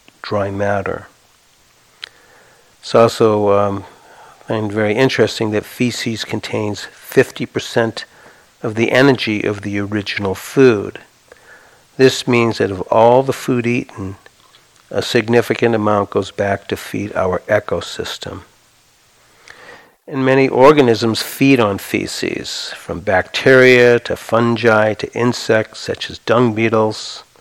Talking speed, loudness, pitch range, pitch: 115 wpm, -15 LUFS, 105-120 Hz, 115 Hz